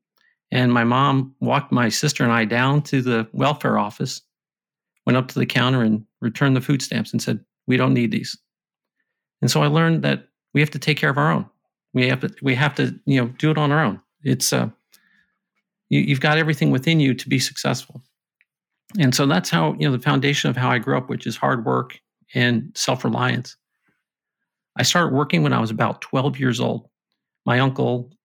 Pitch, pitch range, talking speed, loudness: 135 Hz, 125-150 Hz, 205 wpm, -20 LUFS